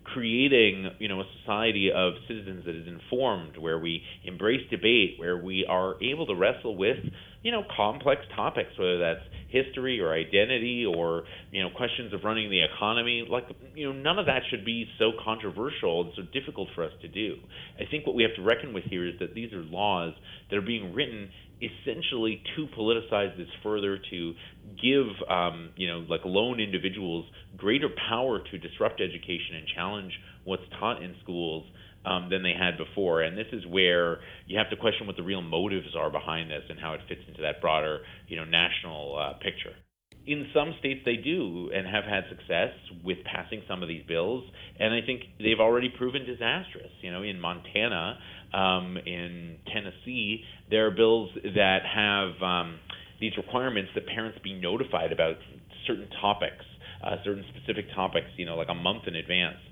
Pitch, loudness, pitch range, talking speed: 95 Hz, -29 LUFS, 90-110 Hz, 185 wpm